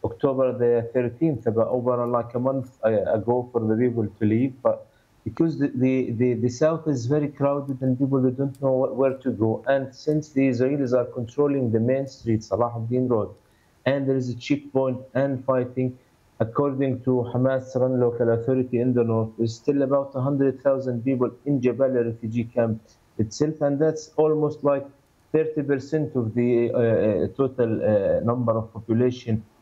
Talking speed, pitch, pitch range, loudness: 170 wpm, 130 Hz, 120-140 Hz, -24 LUFS